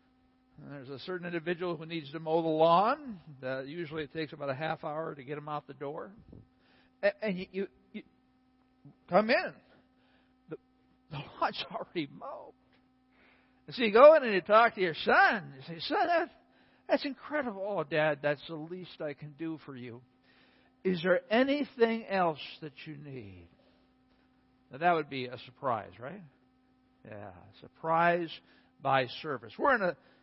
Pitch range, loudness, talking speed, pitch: 135-190 Hz, -30 LUFS, 165 wpm, 160 Hz